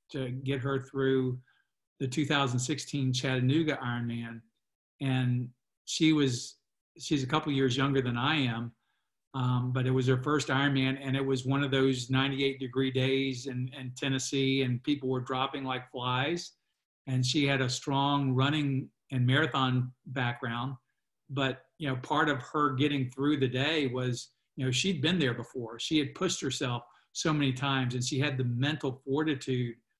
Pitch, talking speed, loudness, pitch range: 135 Hz, 170 wpm, -30 LUFS, 130-140 Hz